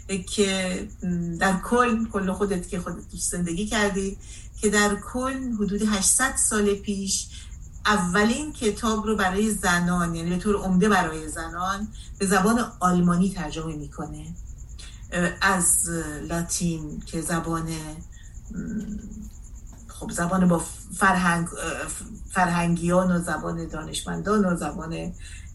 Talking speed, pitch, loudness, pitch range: 105 wpm, 185 Hz, -24 LUFS, 170-205 Hz